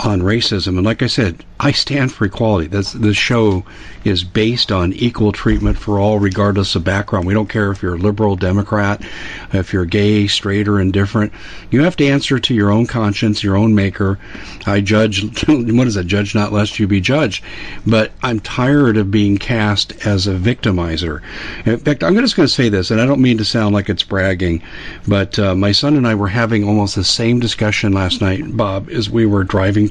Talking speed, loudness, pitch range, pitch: 210 wpm, -15 LUFS, 100-115 Hz, 105 Hz